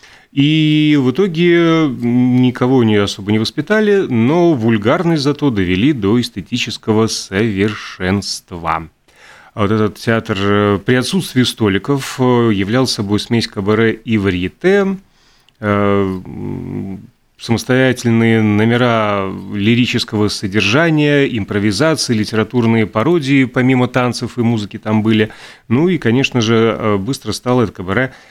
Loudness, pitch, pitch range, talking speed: -14 LUFS, 115 Hz, 105-130 Hz, 100 wpm